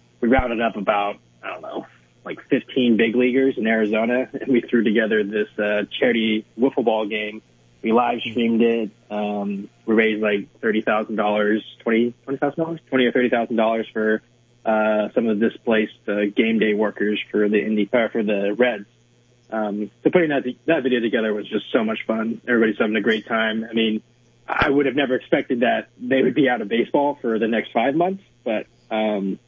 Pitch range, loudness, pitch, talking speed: 105-120 Hz, -21 LUFS, 110 Hz, 190 wpm